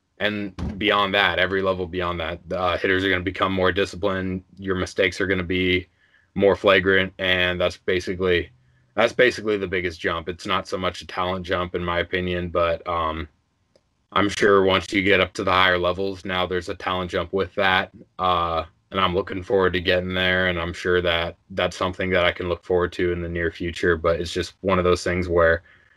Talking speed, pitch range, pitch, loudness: 215 wpm, 90-95 Hz, 90 Hz, -22 LUFS